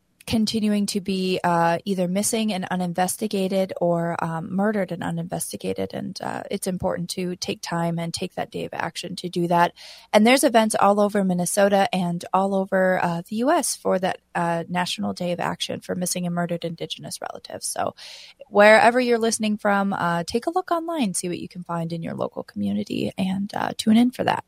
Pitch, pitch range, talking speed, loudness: 185 Hz, 175-210 Hz, 195 wpm, -23 LUFS